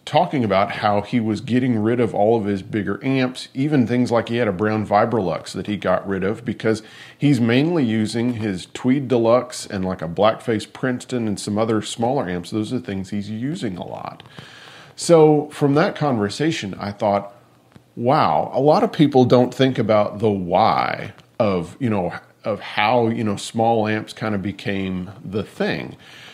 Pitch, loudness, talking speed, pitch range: 115 Hz, -20 LUFS, 185 wpm, 100-130 Hz